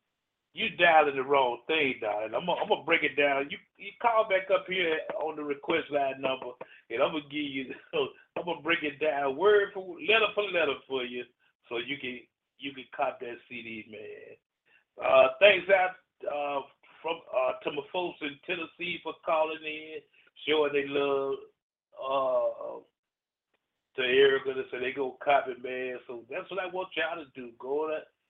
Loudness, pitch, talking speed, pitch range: -29 LUFS, 160 Hz, 180 wpm, 140-205 Hz